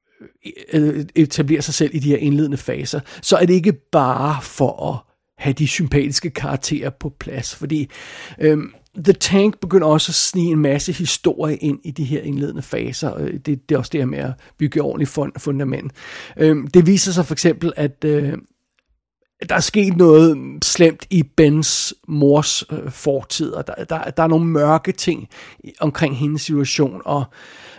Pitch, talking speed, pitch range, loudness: 150 Hz, 175 wpm, 145-165 Hz, -18 LUFS